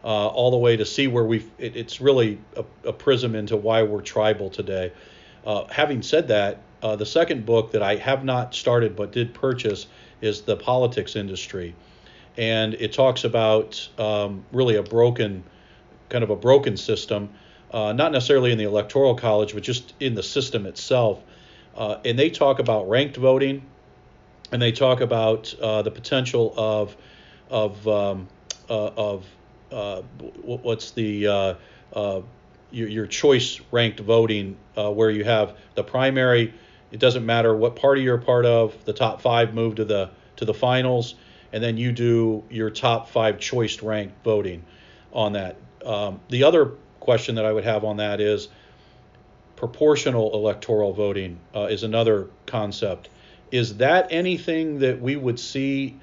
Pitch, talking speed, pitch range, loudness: 110 Hz, 165 wpm, 105-125 Hz, -22 LUFS